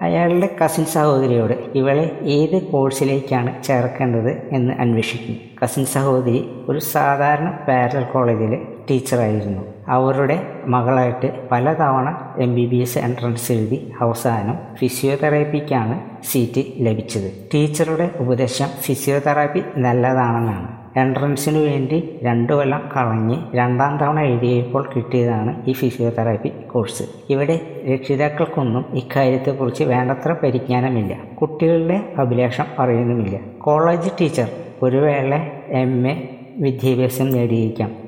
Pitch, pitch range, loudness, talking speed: 130 Hz, 120-145 Hz, -19 LUFS, 95 wpm